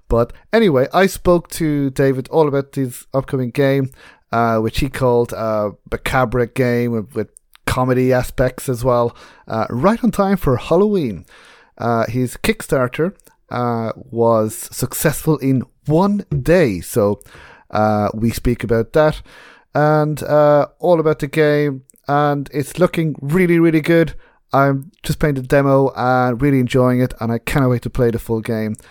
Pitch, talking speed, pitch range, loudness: 130 Hz, 160 wpm, 120-150 Hz, -17 LUFS